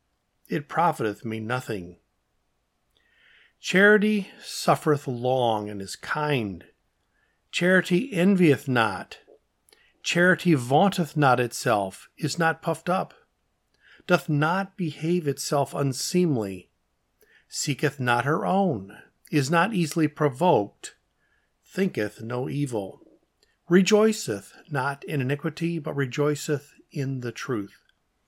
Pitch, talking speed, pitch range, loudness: 150 Hz, 100 wpm, 125-175 Hz, -25 LUFS